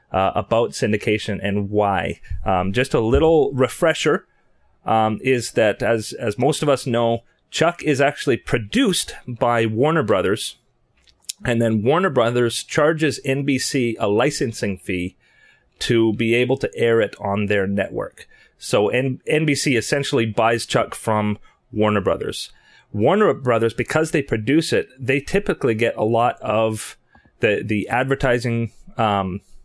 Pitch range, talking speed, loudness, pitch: 105-135 Hz, 140 wpm, -20 LUFS, 115 Hz